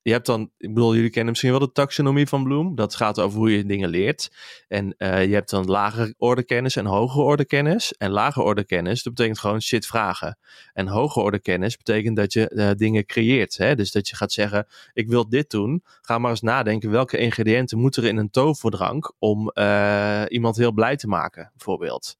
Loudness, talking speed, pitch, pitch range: -22 LUFS, 215 wpm, 115 Hz, 105-120 Hz